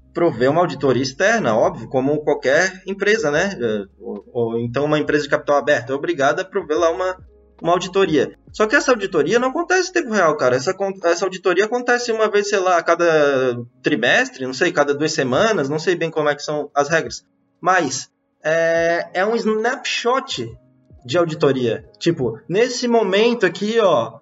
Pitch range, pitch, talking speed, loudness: 145-205 Hz, 165 Hz, 180 wpm, -18 LUFS